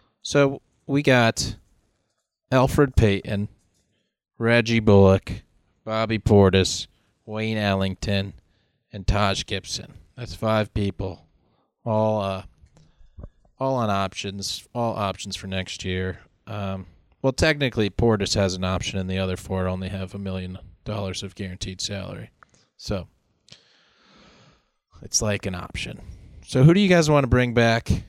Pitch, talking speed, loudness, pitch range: 100 Hz, 130 wpm, -23 LUFS, 95-115 Hz